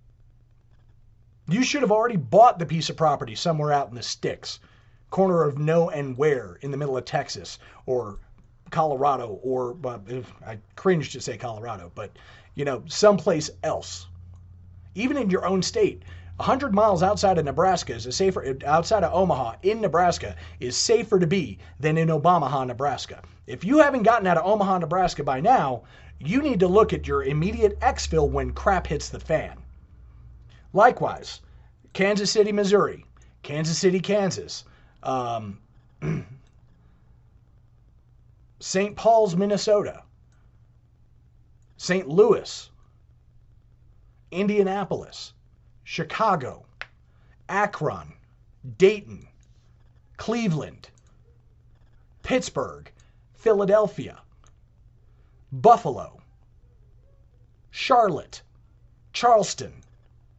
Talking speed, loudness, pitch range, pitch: 110 wpm, -23 LUFS, 115-190 Hz, 140 Hz